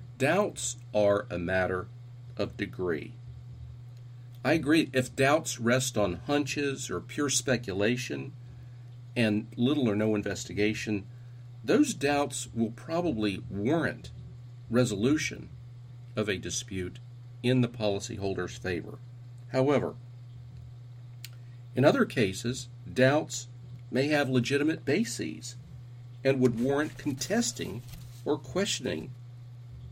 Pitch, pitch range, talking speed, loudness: 120 Hz, 120-130 Hz, 100 wpm, -29 LUFS